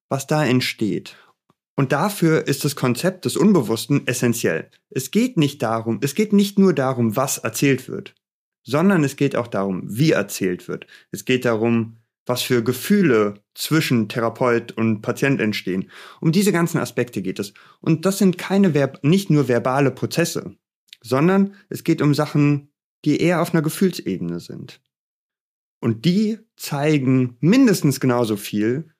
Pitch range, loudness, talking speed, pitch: 120-165 Hz, -20 LUFS, 150 wpm, 140 Hz